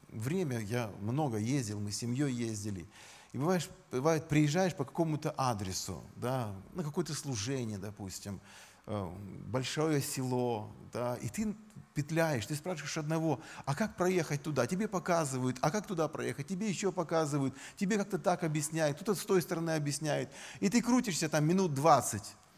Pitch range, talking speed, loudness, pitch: 120-175 Hz, 150 wpm, -34 LUFS, 150 Hz